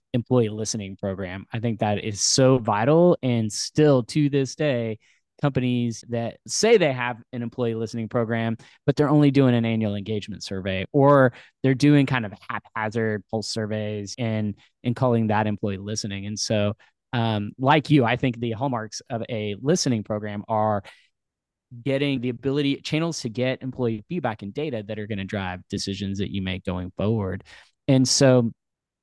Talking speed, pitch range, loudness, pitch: 170 wpm, 105-130 Hz, -24 LUFS, 115 Hz